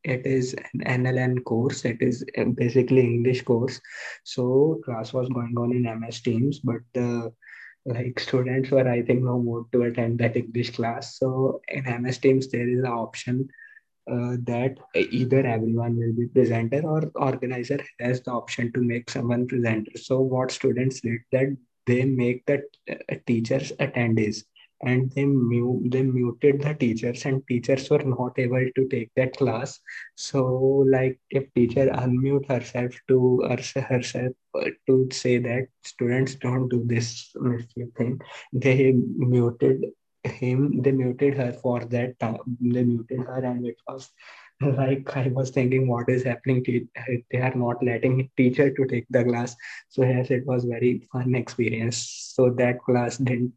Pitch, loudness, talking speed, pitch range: 125 Hz, -24 LUFS, 160 wpm, 120-130 Hz